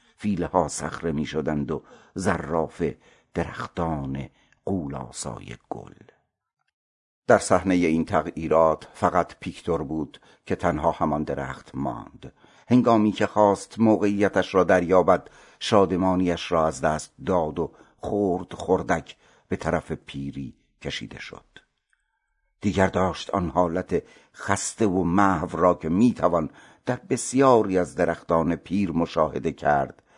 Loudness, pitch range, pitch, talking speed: -24 LUFS, 80-100 Hz, 90 Hz, 110 wpm